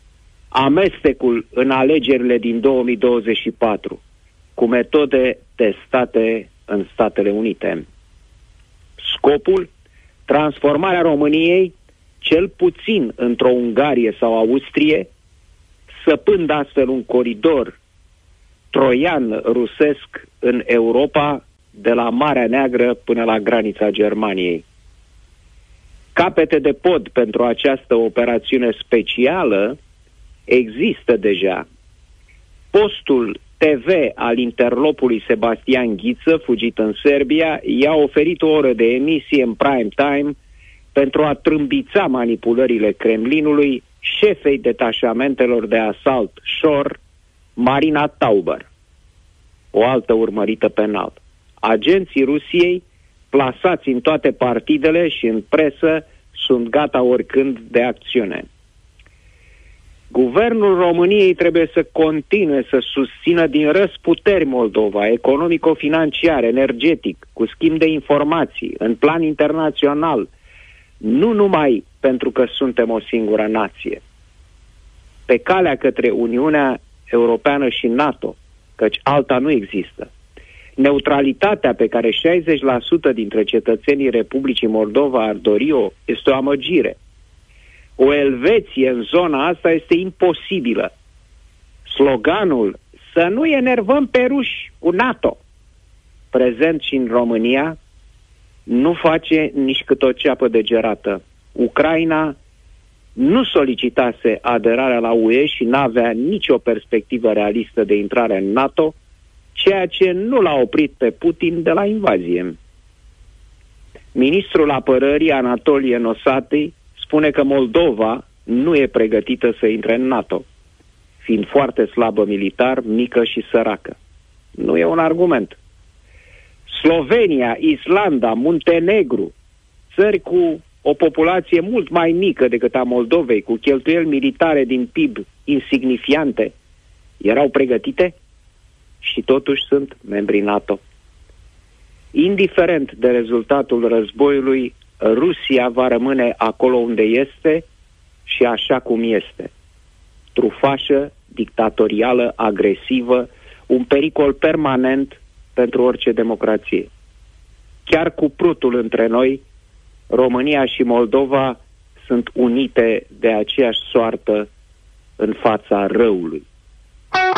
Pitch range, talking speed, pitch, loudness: 105-150 Hz, 105 wpm, 125 Hz, -16 LUFS